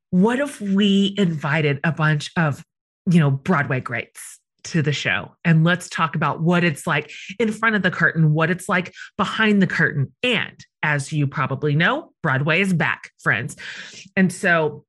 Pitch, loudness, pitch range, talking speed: 165 Hz, -20 LUFS, 150-190 Hz, 175 wpm